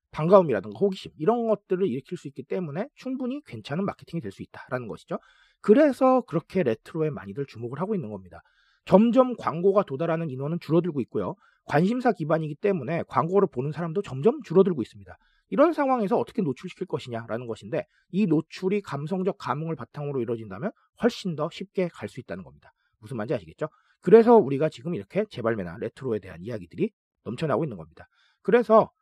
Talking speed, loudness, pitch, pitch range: 445 characters per minute, -26 LUFS, 175 Hz, 135-205 Hz